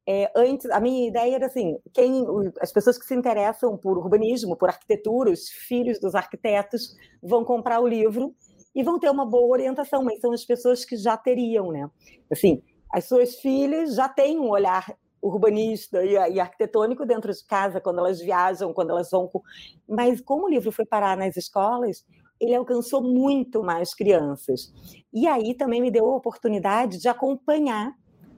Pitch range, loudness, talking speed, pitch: 200-250 Hz, -23 LUFS, 170 wpm, 235 Hz